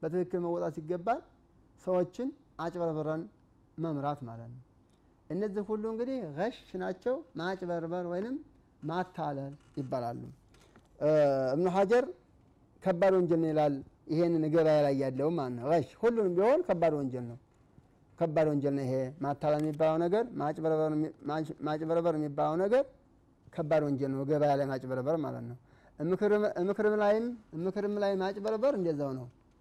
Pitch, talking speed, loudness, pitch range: 160 Hz, 120 wpm, -31 LUFS, 140-185 Hz